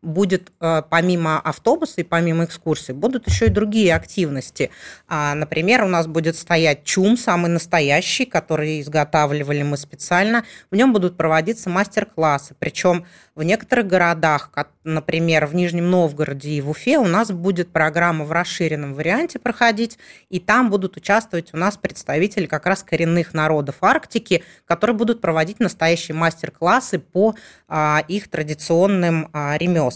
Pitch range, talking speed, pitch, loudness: 155-195 Hz, 135 wpm, 170 Hz, -19 LUFS